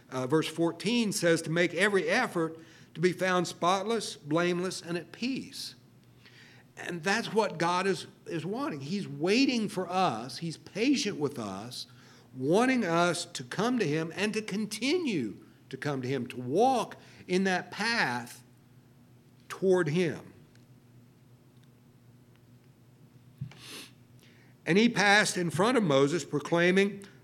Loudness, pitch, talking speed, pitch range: -29 LUFS, 165 Hz, 130 wpm, 125-195 Hz